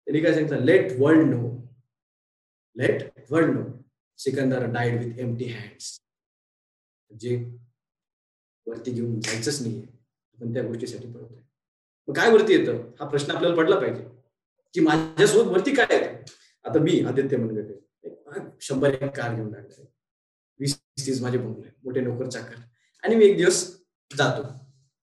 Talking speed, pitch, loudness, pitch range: 145 wpm, 130 Hz, -23 LUFS, 120-145 Hz